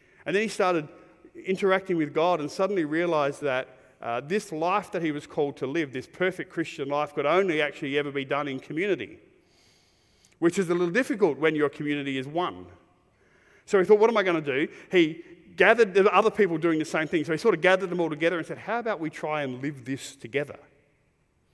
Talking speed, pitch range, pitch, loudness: 215 wpm, 145-190 Hz, 165 Hz, -26 LUFS